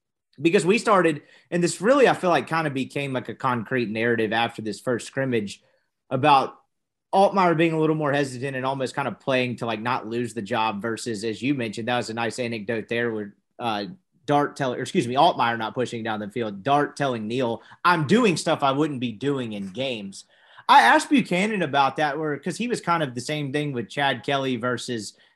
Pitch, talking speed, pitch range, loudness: 135 Hz, 215 wpm, 115-155 Hz, -23 LUFS